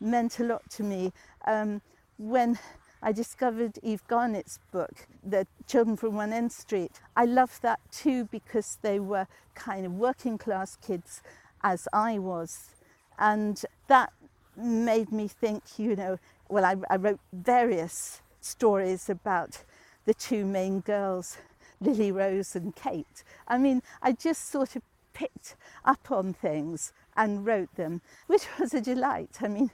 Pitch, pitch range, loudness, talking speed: 220 Hz, 195-240 Hz, -29 LUFS, 150 wpm